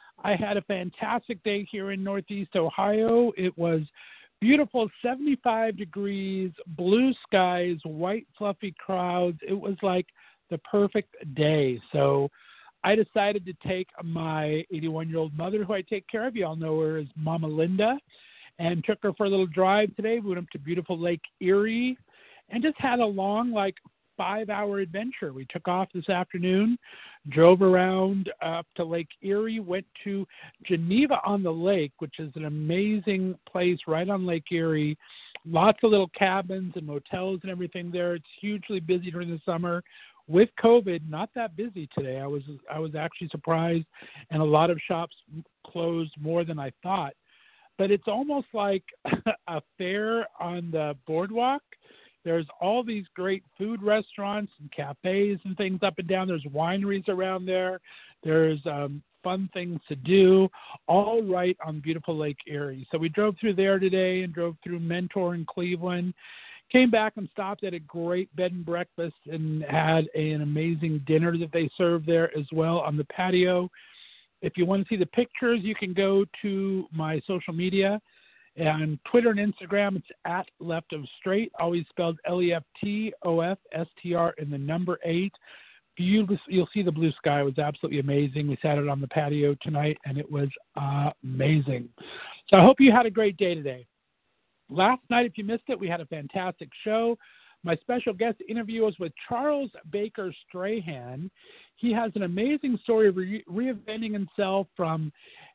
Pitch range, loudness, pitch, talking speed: 160-205 Hz, -27 LUFS, 180 Hz, 170 wpm